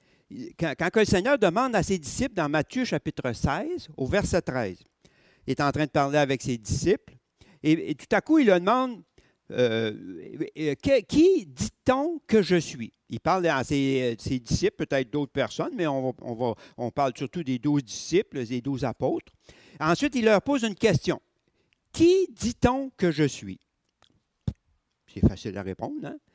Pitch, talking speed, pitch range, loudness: 155 Hz, 175 wpm, 130-215 Hz, -26 LUFS